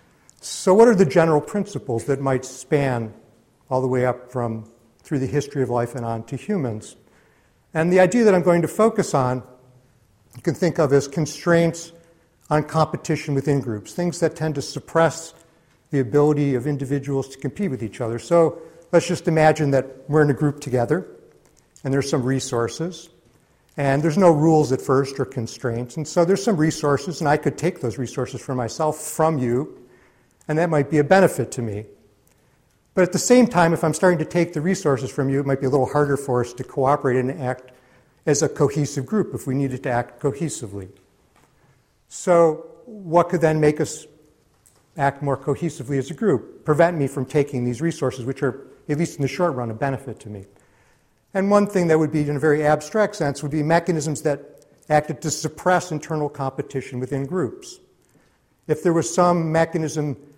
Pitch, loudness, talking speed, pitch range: 145 Hz, -21 LUFS, 195 wpm, 130-165 Hz